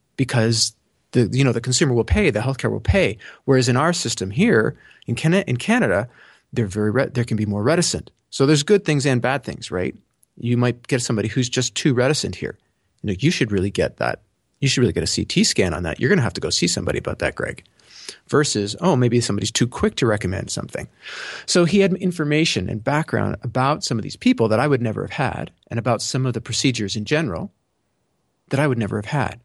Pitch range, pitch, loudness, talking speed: 110-140 Hz, 125 Hz, -20 LUFS, 225 wpm